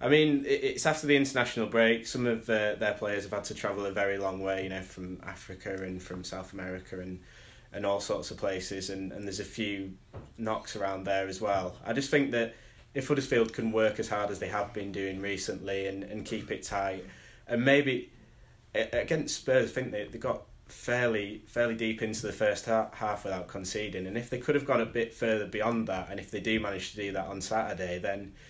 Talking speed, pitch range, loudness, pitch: 225 wpm, 95-115 Hz, -31 LUFS, 105 Hz